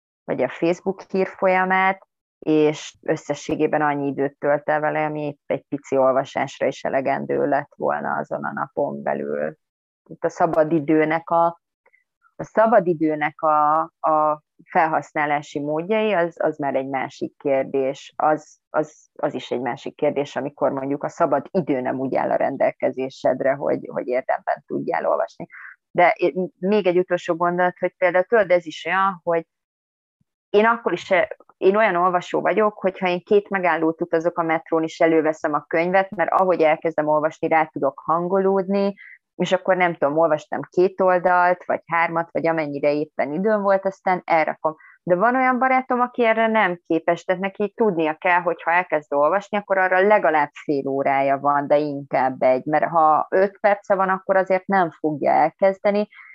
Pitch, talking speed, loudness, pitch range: 165 Hz, 160 wpm, -21 LUFS, 150-190 Hz